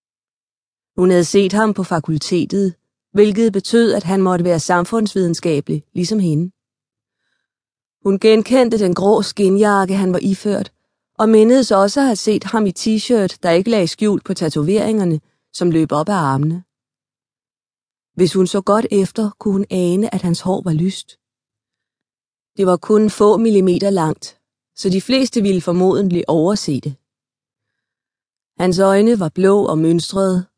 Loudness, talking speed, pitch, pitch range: -16 LUFS, 145 wpm, 190 Hz, 170-210 Hz